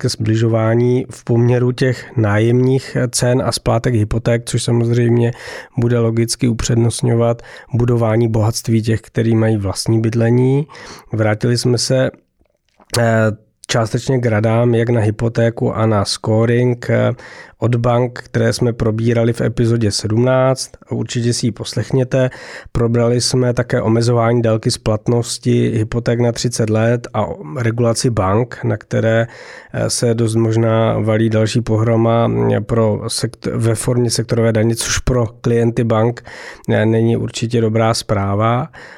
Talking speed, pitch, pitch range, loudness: 125 wpm, 115 Hz, 115-120 Hz, -16 LUFS